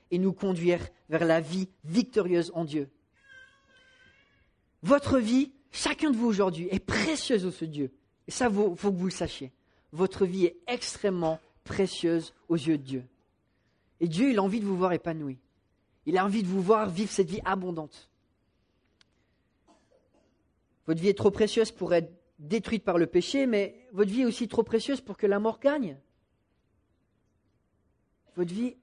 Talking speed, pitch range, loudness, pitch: 170 wpm, 160-220 Hz, -28 LUFS, 185 Hz